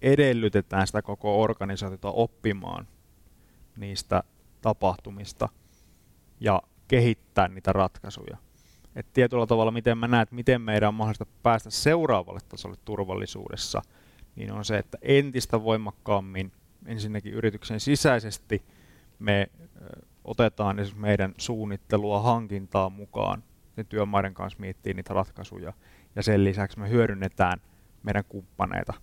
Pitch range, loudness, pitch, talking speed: 95-115 Hz, -27 LUFS, 105 Hz, 110 wpm